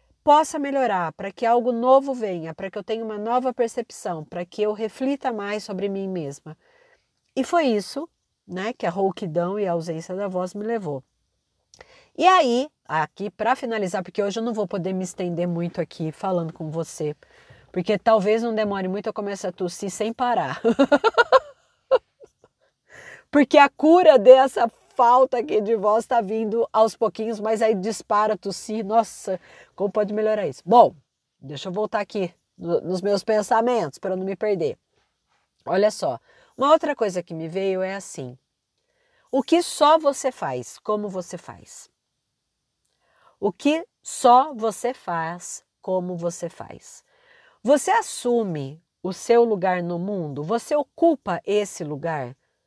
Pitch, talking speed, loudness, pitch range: 210 Hz, 155 wpm, -22 LUFS, 180-245 Hz